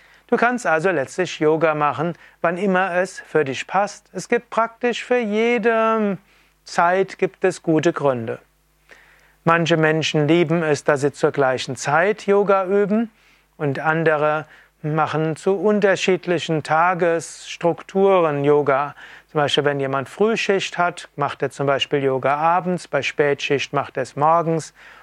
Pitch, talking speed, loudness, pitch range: 165 Hz, 140 wpm, -20 LUFS, 150-195 Hz